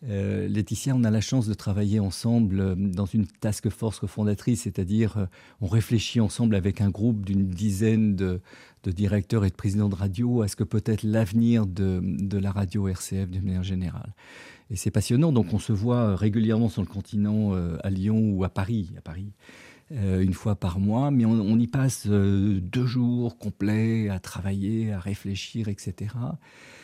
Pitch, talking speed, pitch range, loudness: 105 Hz, 180 wpm, 100-115 Hz, -26 LUFS